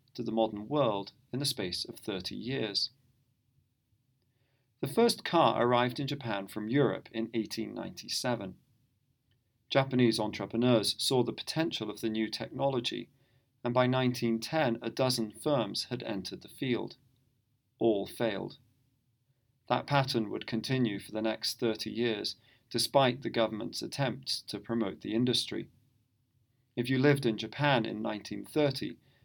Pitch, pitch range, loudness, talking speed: 120 Hz, 115-130 Hz, -32 LUFS, 135 wpm